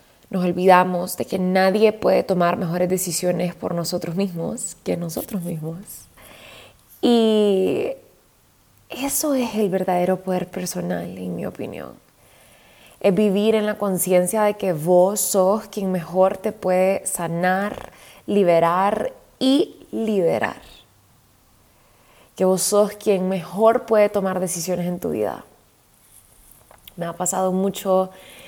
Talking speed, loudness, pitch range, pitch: 120 wpm, -21 LUFS, 180-205 Hz, 185 Hz